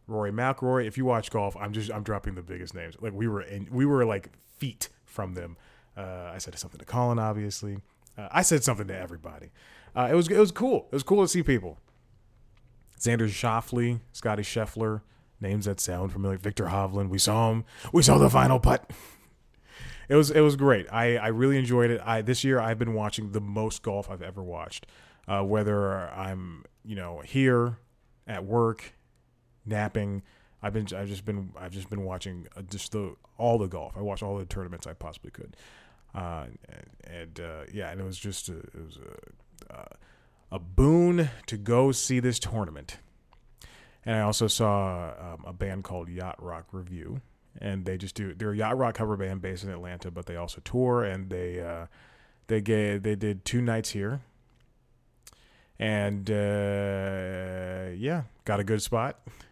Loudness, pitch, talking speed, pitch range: -28 LUFS, 105 Hz, 185 wpm, 95-120 Hz